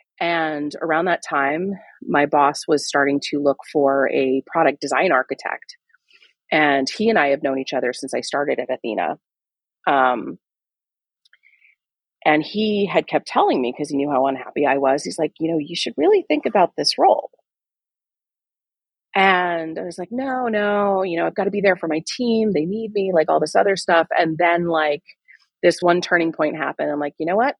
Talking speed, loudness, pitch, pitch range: 195 wpm, -20 LUFS, 165 Hz, 145-200 Hz